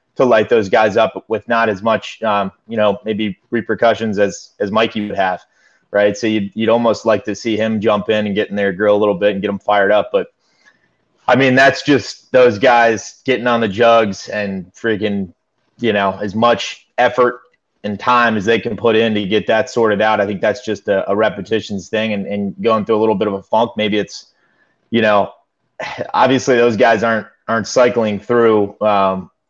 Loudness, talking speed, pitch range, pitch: -15 LUFS, 210 wpm, 100-115 Hz, 110 Hz